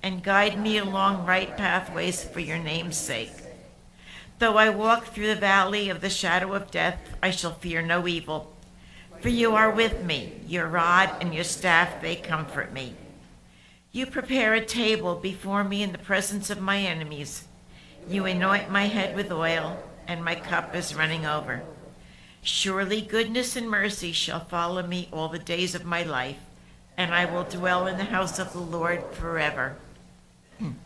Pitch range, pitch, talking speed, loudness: 165-200 Hz, 180 Hz, 170 wpm, -26 LUFS